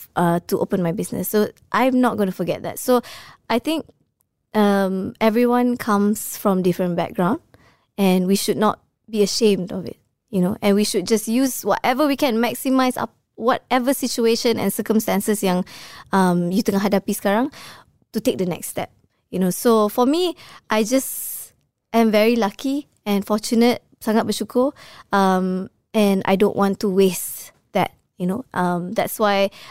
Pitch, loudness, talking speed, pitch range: 210 Hz, -20 LUFS, 165 wpm, 195-240 Hz